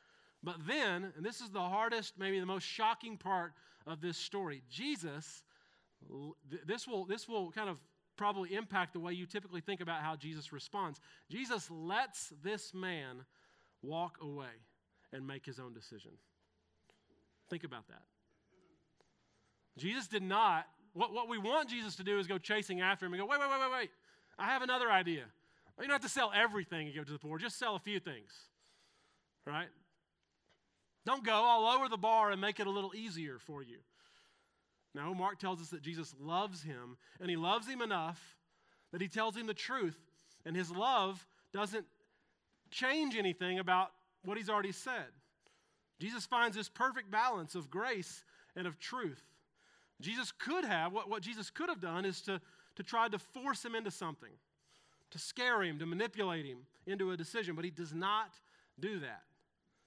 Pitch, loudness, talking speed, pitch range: 190 Hz, -38 LUFS, 180 wpm, 165-220 Hz